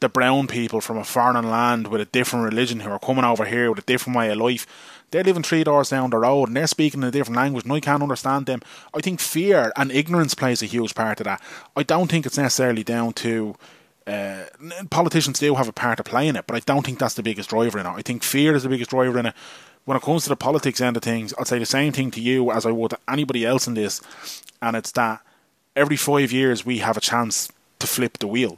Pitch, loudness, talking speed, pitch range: 125 Hz, -21 LUFS, 265 wpm, 115-140 Hz